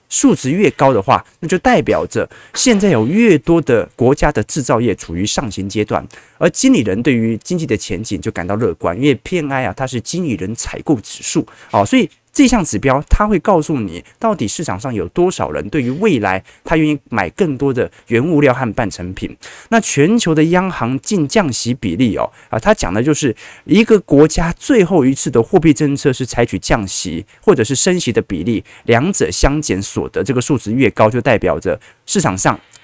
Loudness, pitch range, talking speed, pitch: -15 LUFS, 115-180 Hz, 300 characters per minute, 140 Hz